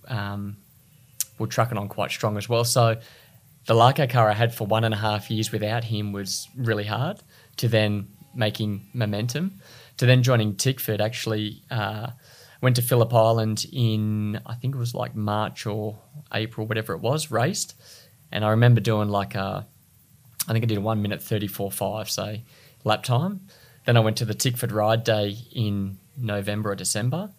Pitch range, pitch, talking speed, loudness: 105-125 Hz, 115 Hz, 185 wpm, -24 LUFS